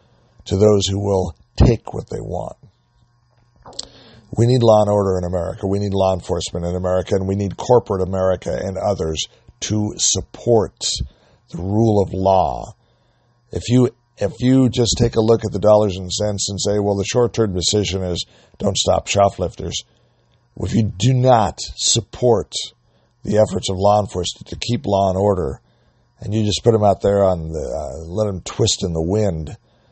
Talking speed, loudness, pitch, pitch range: 180 wpm, -18 LUFS, 105 Hz, 95-115 Hz